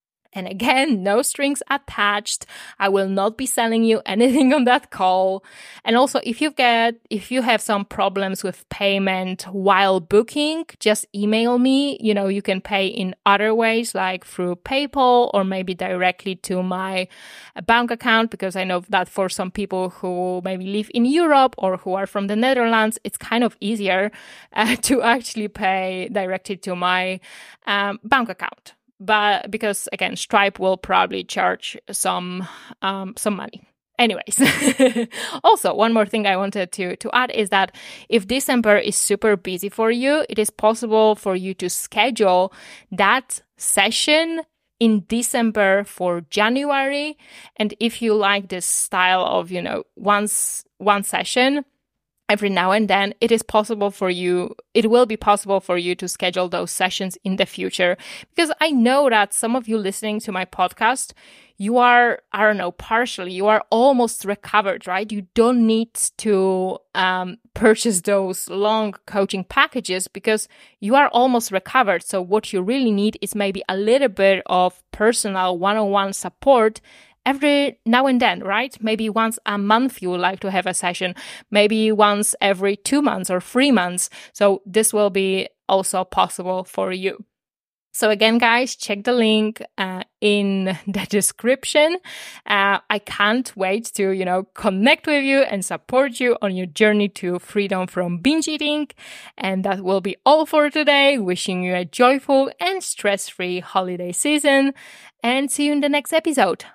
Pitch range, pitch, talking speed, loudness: 190-240 Hz, 210 Hz, 165 wpm, -19 LUFS